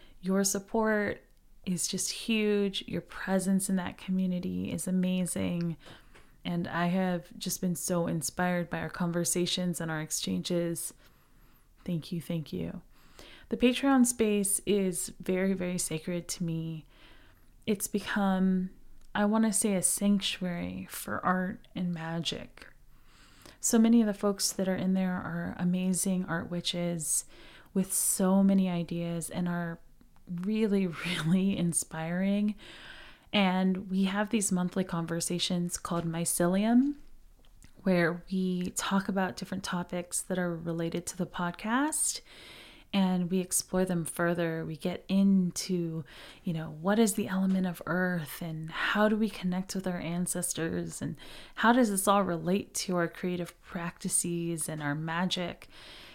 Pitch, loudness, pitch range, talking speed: 180 Hz, -30 LUFS, 170-195 Hz, 140 wpm